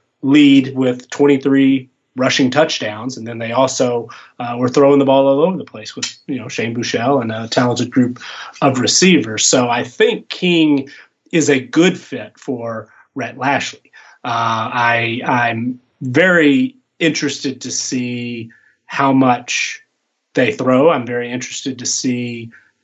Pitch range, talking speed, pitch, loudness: 120-140 Hz, 145 wpm, 130 Hz, -15 LUFS